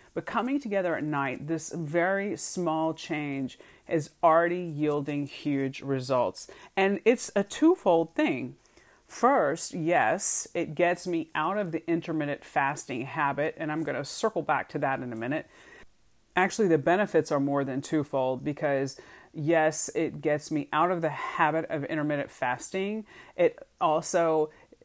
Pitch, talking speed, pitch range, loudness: 160 Hz, 150 wpm, 145-180 Hz, -28 LUFS